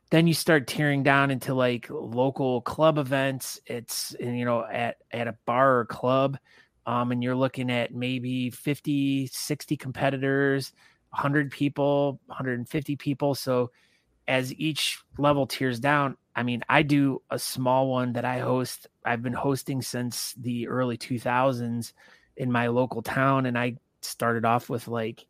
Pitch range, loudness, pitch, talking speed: 120-140 Hz, -26 LUFS, 130 Hz, 155 wpm